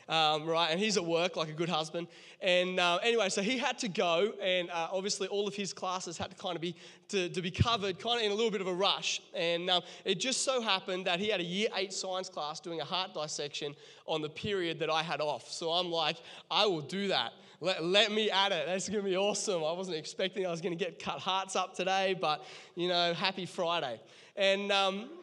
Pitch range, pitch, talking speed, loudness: 170-200 Hz, 185 Hz, 245 wpm, -32 LUFS